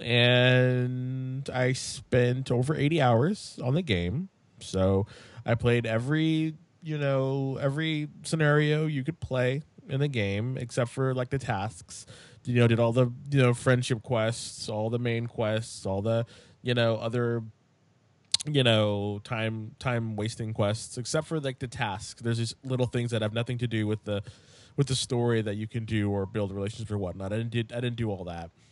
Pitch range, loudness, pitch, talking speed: 110-130 Hz, -28 LUFS, 120 Hz, 185 wpm